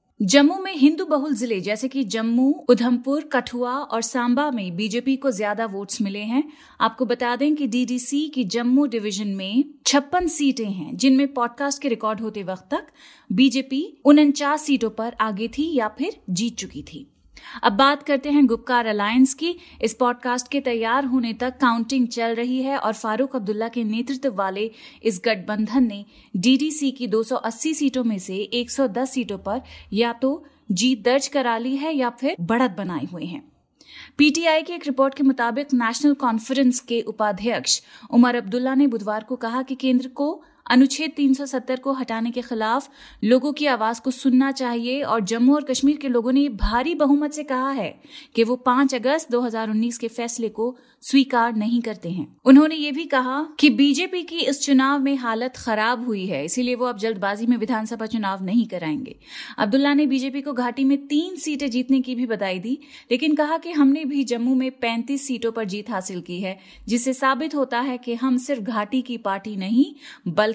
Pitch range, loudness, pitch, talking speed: 230-280 Hz, -21 LUFS, 250 Hz, 180 wpm